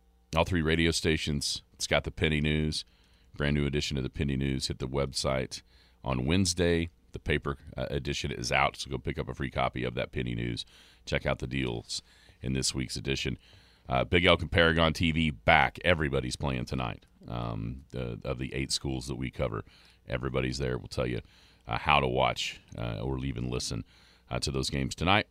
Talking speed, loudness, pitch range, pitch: 195 wpm, -30 LUFS, 65-80 Hz, 65 Hz